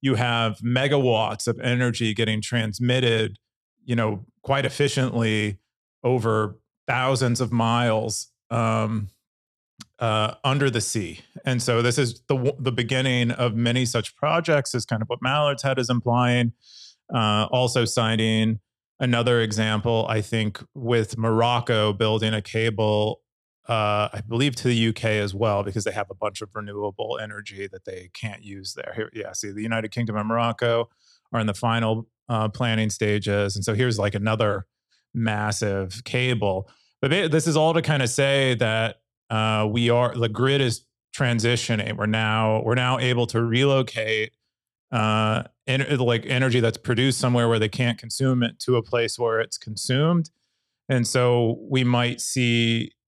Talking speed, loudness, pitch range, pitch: 160 wpm, -23 LUFS, 110-125 Hz, 115 Hz